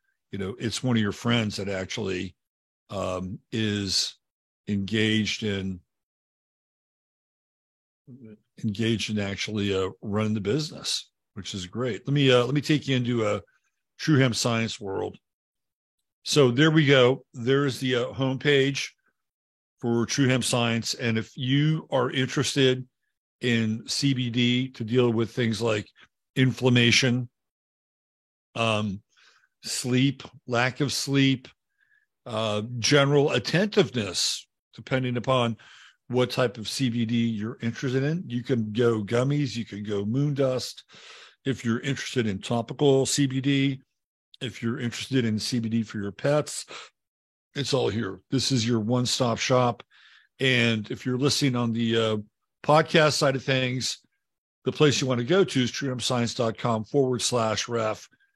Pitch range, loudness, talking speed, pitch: 110-135 Hz, -25 LUFS, 135 wpm, 125 Hz